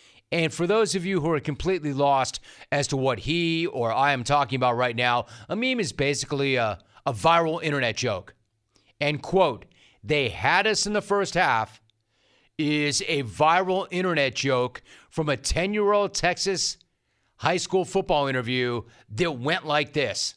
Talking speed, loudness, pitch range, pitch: 170 wpm, -24 LUFS, 125-180 Hz, 145 Hz